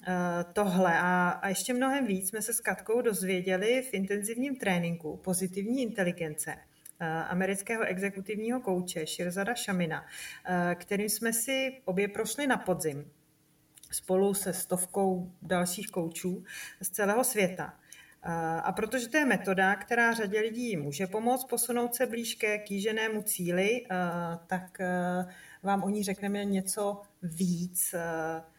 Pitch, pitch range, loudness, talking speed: 195 Hz, 180-220 Hz, -31 LUFS, 120 wpm